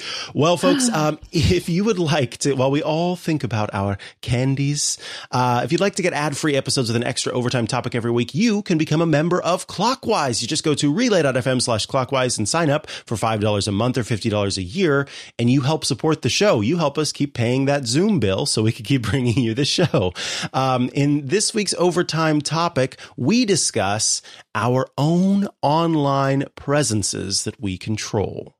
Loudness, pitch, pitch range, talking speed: -20 LUFS, 140 Hz, 120-160 Hz, 195 wpm